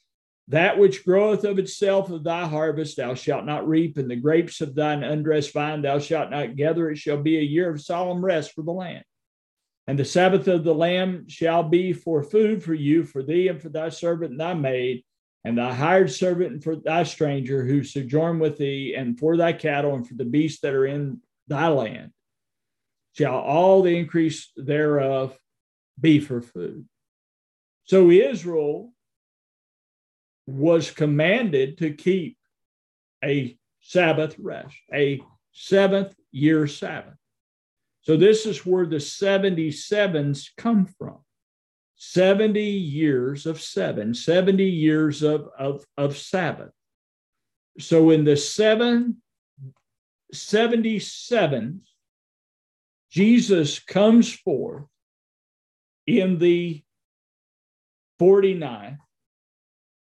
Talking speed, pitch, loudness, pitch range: 130 wpm, 160 Hz, -22 LUFS, 145-185 Hz